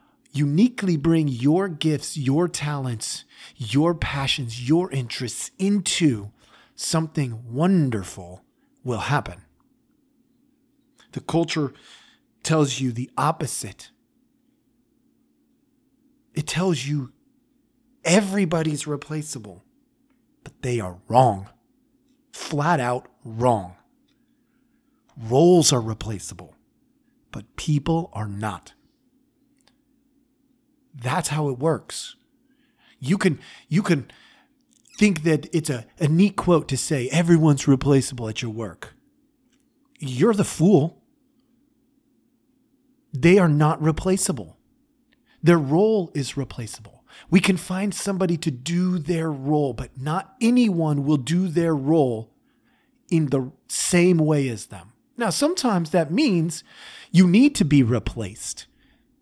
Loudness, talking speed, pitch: -22 LUFS, 105 wpm, 170 Hz